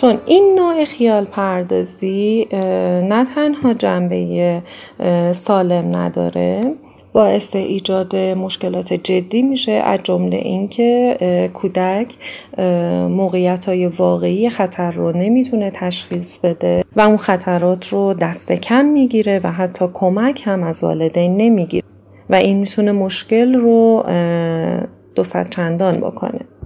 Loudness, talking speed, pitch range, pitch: -16 LUFS, 110 wpm, 175-225 Hz, 190 Hz